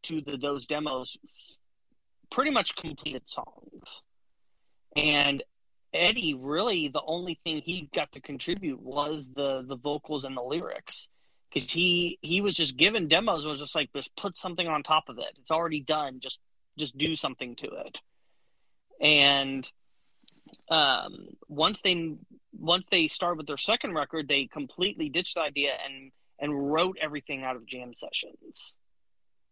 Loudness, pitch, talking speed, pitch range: -28 LUFS, 150 Hz, 155 wpm, 140-175 Hz